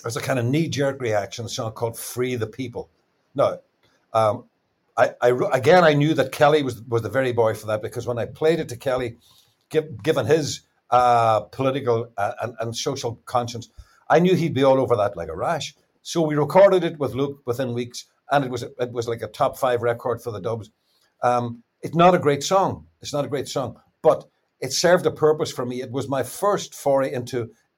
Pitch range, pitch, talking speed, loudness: 120-145 Hz, 125 Hz, 220 wpm, -22 LUFS